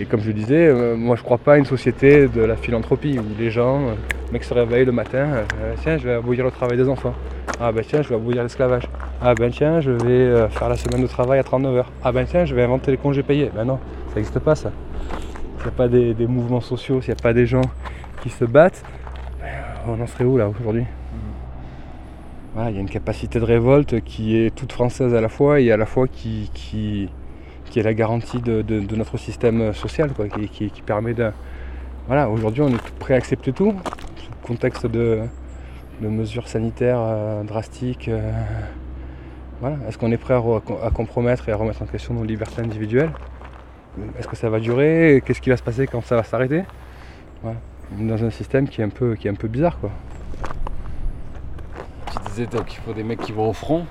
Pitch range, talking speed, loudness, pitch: 105-125 Hz, 235 wpm, -20 LUFS, 115 Hz